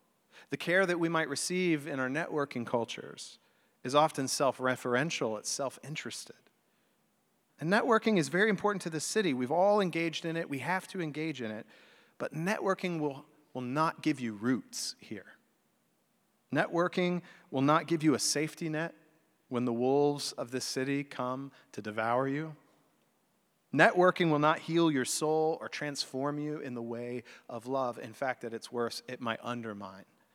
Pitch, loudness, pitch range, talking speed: 150 Hz, -32 LUFS, 130-165 Hz, 165 wpm